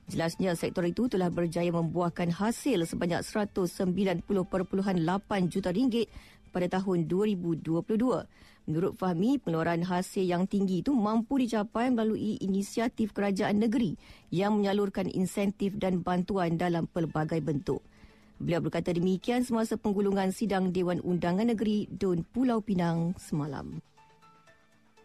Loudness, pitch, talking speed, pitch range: -30 LUFS, 190 Hz, 115 wpm, 175-210 Hz